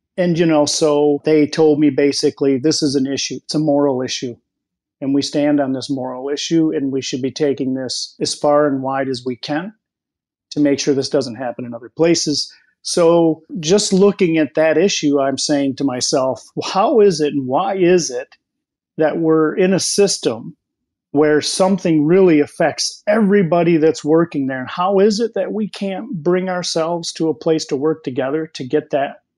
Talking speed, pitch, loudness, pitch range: 190 wpm, 150 Hz, -16 LUFS, 140-175 Hz